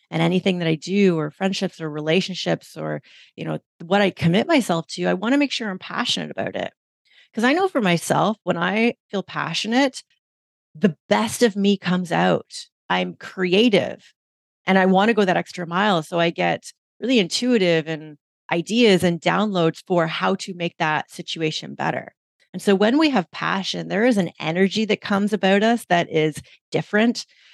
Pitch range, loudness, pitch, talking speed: 165-210 Hz, -21 LUFS, 185 Hz, 185 wpm